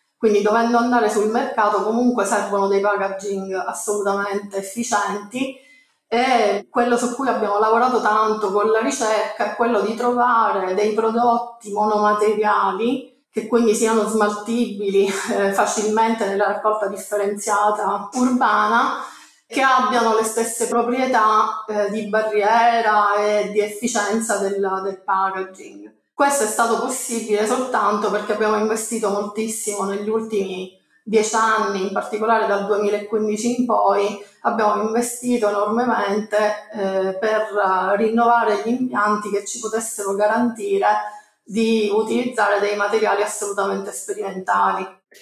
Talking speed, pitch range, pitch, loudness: 120 wpm, 205-230 Hz, 215 Hz, -19 LUFS